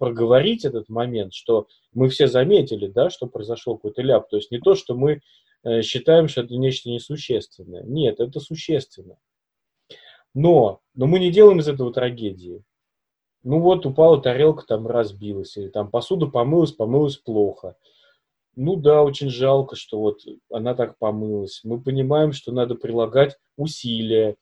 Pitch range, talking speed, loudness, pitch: 115-150 Hz, 150 wpm, -20 LUFS, 125 Hz